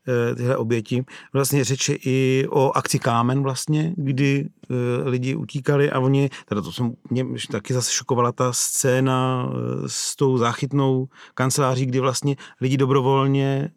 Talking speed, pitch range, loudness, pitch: 135 wpm, 125-140 Hz, -22 LUFS, 130 Hz